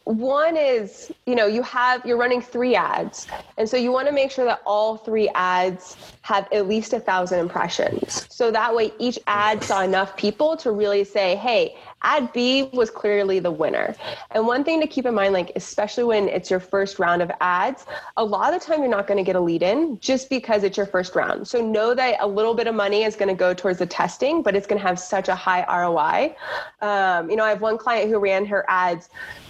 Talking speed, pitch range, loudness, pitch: 235 wpm, 195-250 Hz, -21 LUFS, 215 Hz